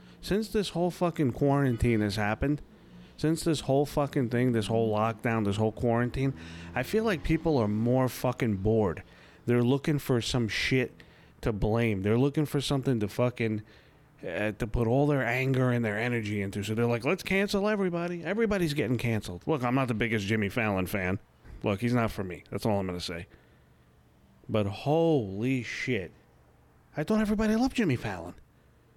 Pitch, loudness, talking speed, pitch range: 120 Hz, -29 LUFS, 180 wpm, 105-145 Hz